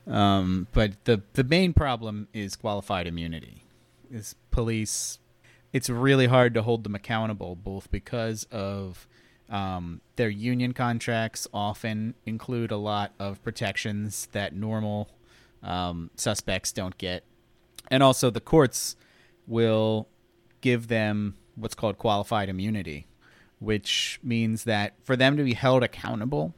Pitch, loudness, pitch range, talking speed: 110 Hz, -27 LUFS, 100-120 Hz, 130 wpm